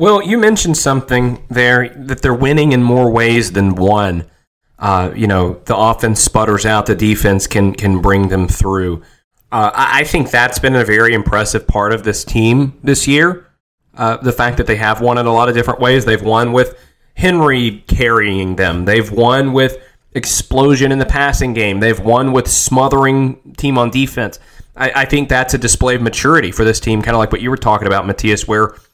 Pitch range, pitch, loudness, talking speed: 105-130 Hz, 115 Hz, -13 LUFS, 195 wpm